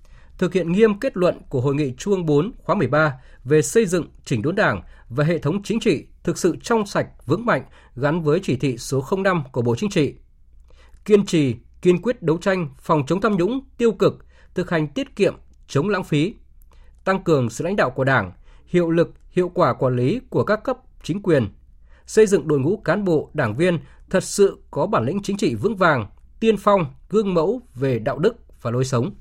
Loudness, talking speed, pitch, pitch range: -21 LUFS, 215 wpm, 165 Hz, 135-195 Hz